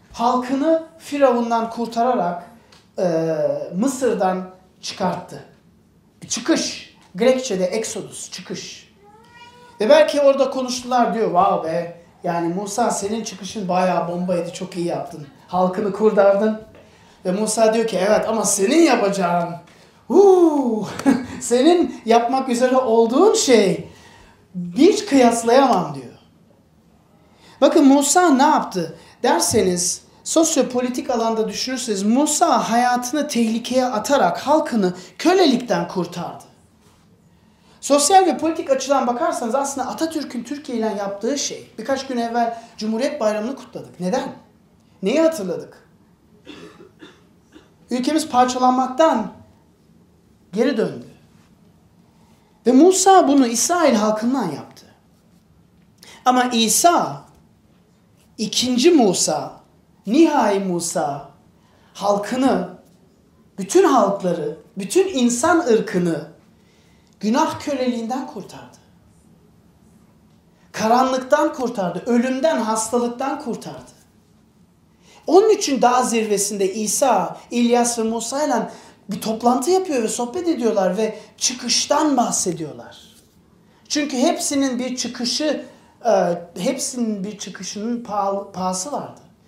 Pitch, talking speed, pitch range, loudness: 235 Hz, 90 wpm, 200-275 Hz, -19 LUFS